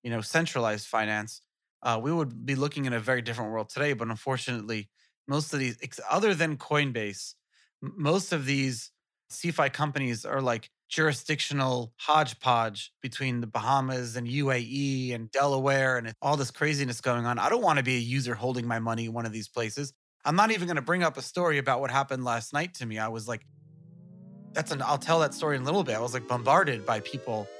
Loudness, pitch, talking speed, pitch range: -28 LUFS, 130 Hz, 210 wpm, 120-145 Hz